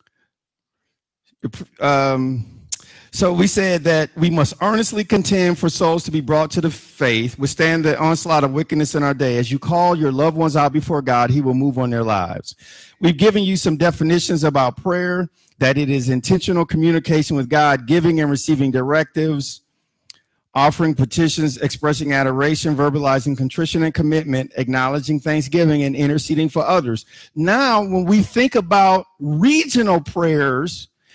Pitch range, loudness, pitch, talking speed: 140-170 Hz, -17 LUFS, 155 Hz, 150 wpm